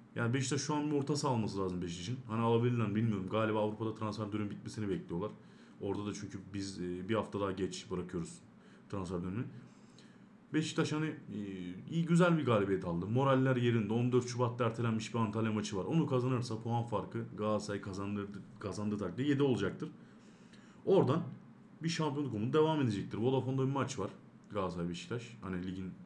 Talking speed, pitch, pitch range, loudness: 160 wpm, 110 Hz, 100-130 Hz, -35 LUFS